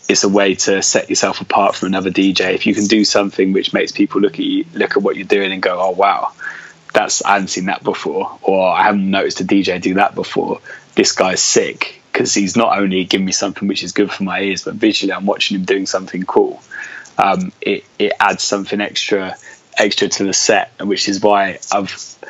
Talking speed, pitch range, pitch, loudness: 225 wpm, 95-105 Hz, 100 Hz, -15 LUFS